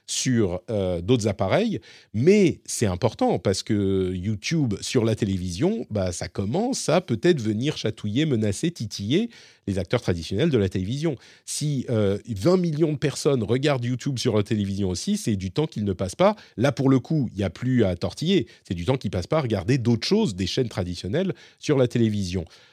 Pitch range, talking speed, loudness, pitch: 100-145 Hz, 195 wpm, -24 LUFS, 115 Hz